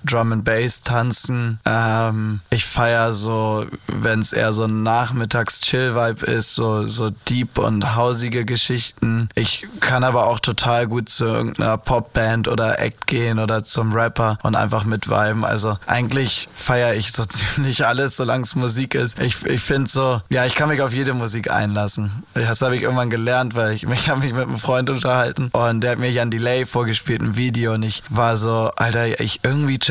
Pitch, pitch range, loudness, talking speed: 115 Hz, 110-125 Hz, -19 LUFS, 190 wpm